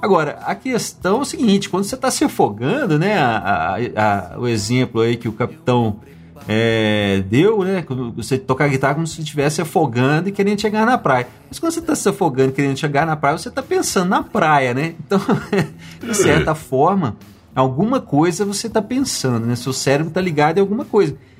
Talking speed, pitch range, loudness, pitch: 200 wpm, 125-205 Hz, -18 LUFS, 155 Hz